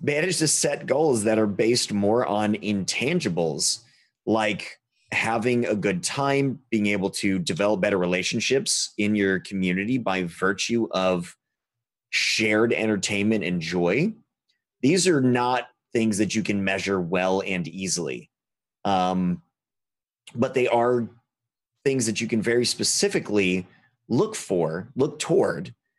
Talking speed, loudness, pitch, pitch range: 130 wpm, -24 LUFS, 110 Hz, 95-120 Hz